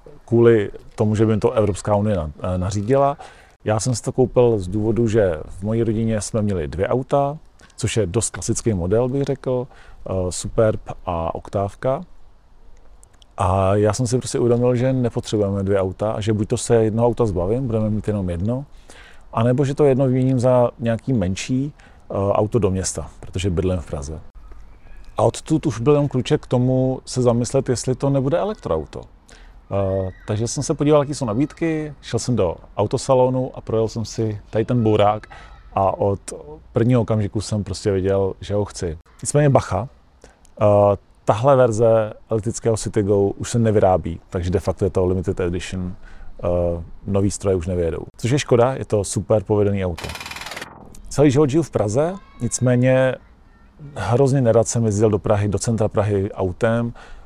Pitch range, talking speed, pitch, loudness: 100-125 Hz, 165 wpm, 110 Hz, -20 LUFS